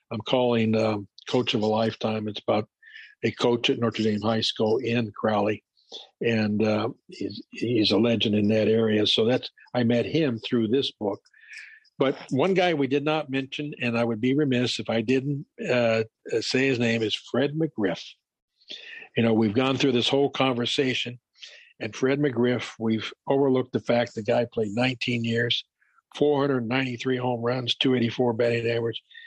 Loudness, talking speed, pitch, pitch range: -25 LUFS, 170 wpm, 120 Hz, 110-135 Hz